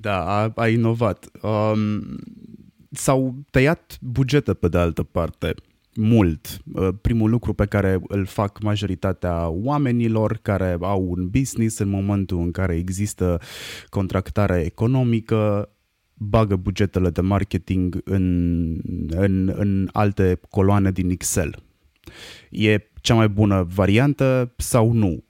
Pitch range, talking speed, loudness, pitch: 90-115 Hz, 120 wpm, -21 LUFS, 100 Hz